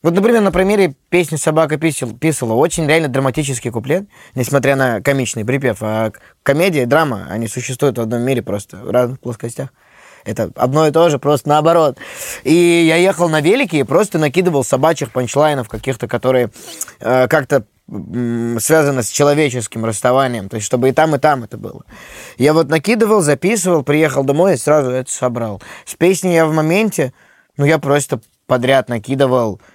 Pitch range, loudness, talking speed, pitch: 125-160 Hz, -15 LUFS, 170 wpm, 140 Hz